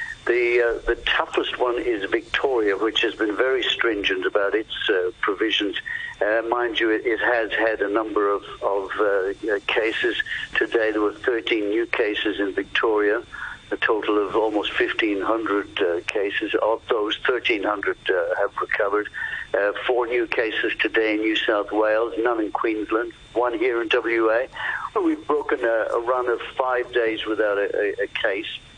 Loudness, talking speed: -22 LUFS, 165 wpm